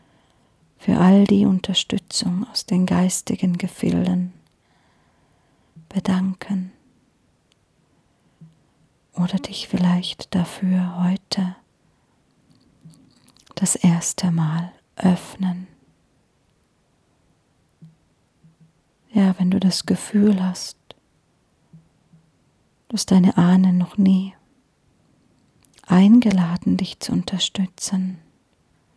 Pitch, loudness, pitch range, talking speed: 185 Hz, -20 LUFS, 165-190 Hz, 70 wpm